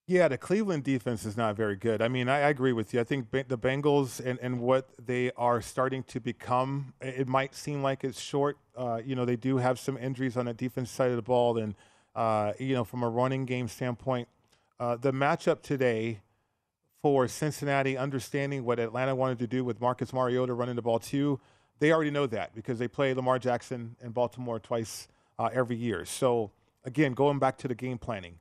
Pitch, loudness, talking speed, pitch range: 125 Hz, -30 LUFS, 205 wpm, 120-135 Hz